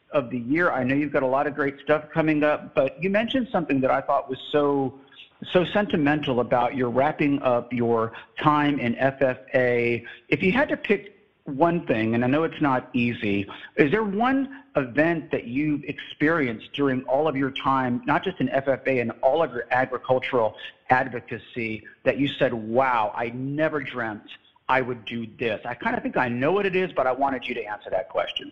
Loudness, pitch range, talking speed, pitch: -24 LUFS, 125-155 Hz, 200 wpm, 135 Hz